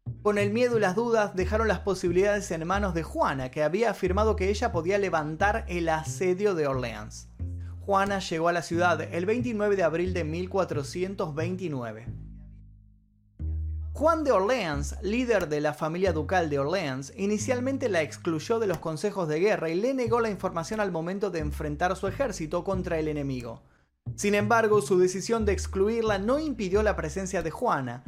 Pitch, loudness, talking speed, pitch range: 180 Hz, -27 LUFS, 170 wpm, 145-205 Hz